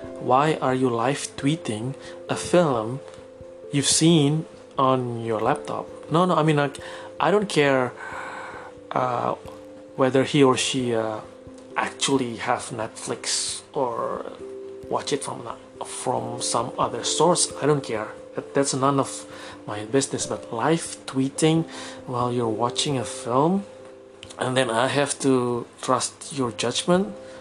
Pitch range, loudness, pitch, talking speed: 120-150 Hz, -24 LUFS, 130 Hz, 135 wpm